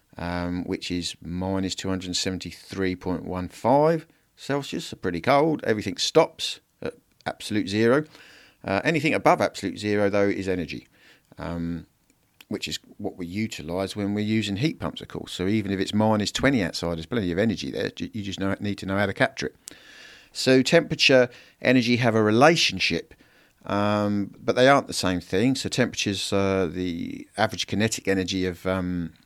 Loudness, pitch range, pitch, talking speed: -24 LUFS, 90-110 Hz, 95 Hz, 160 wpm